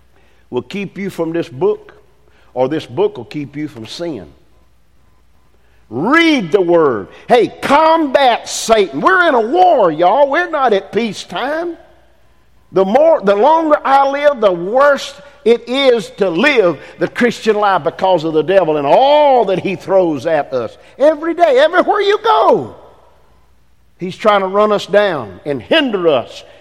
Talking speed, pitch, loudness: 160 wpm, 230 Hz, -13 LUFS